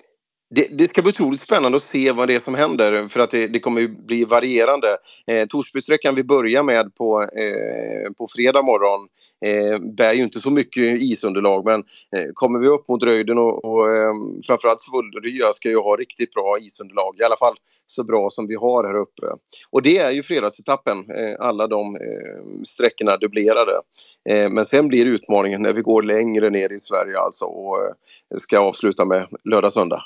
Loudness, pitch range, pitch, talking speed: -19 LUFS, 105-135 Hz, 115 Hz, 170 wpm